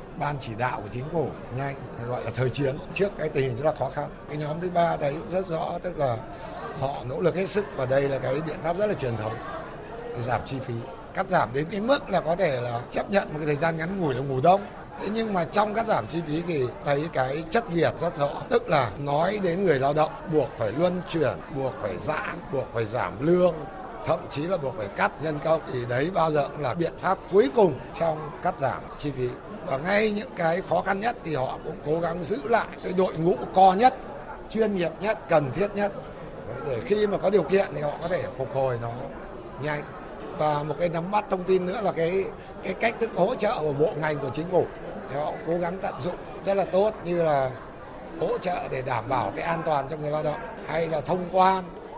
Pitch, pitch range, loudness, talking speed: 160 Hz, 140-190 Hz, -26 LUFS, 240 wpm